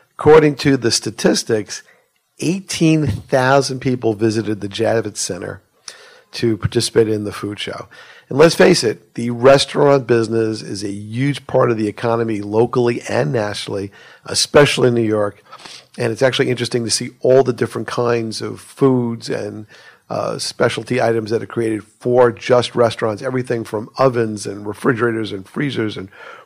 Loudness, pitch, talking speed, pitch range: -17 LUFS, 120 Hz, 155 wpm, 110-130 Hz